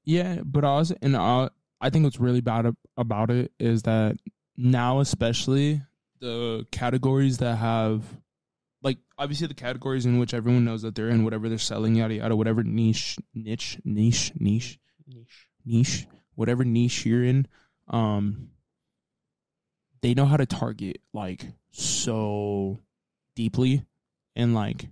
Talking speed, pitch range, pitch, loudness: 140 wpm, 115-135 Hz, 120 Hz, -25 LUFS